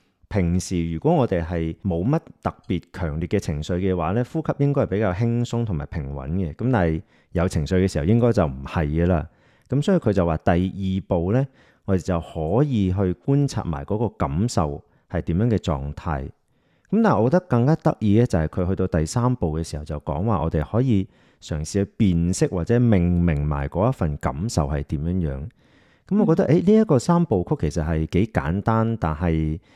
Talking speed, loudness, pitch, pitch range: 295 characters per minute, -22 LUFS, 95 Hz, 80-115 Hz